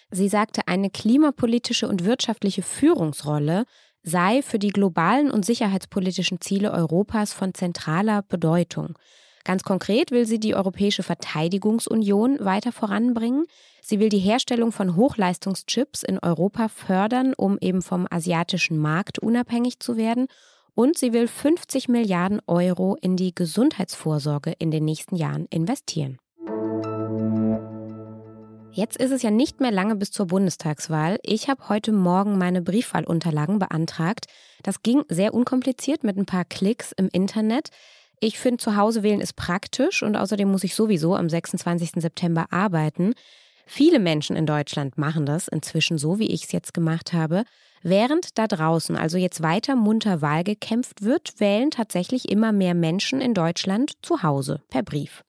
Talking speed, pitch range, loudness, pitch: 150 wpm, 170-230 Hz, -23 LUFS, 195 Hz